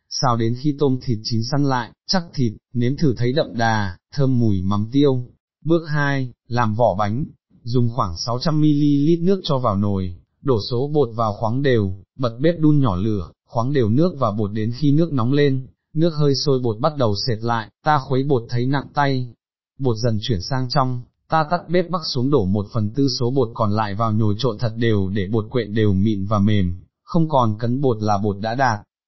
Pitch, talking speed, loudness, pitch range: 125 Hz, 215 wpm, -20 LUFS, 110-140 Hz